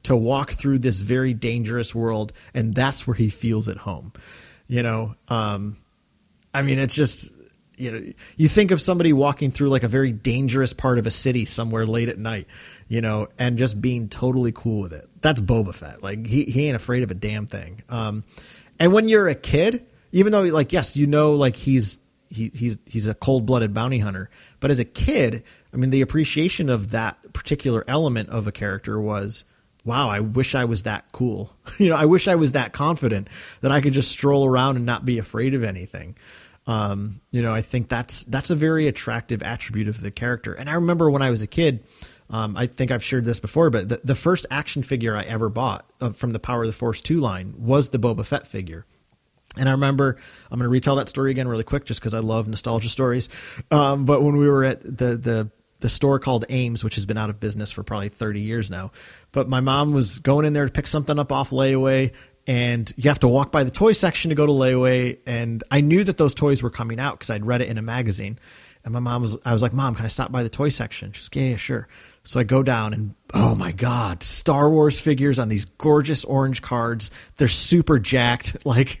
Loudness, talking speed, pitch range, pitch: -21 LUFS, 230 wpm, 110-140 Hz, 125 Hz